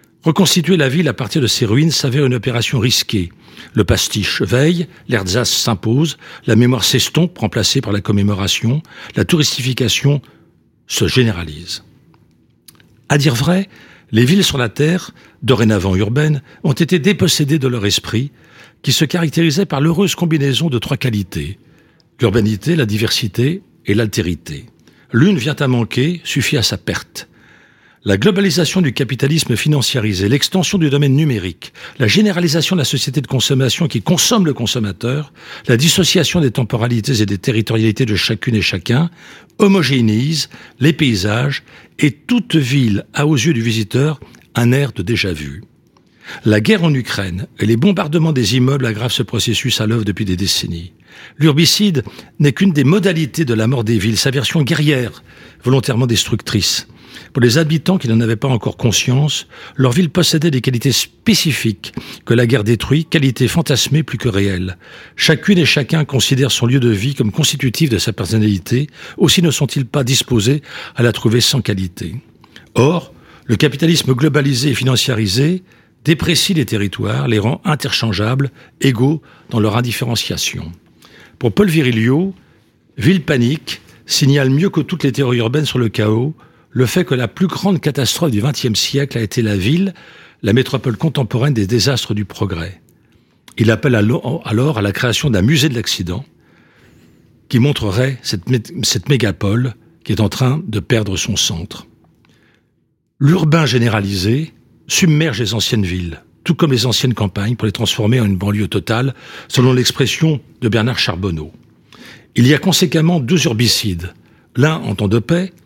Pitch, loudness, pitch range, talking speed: 130 Hz, -15 LUFS, 110-155 Hz, 155 wpm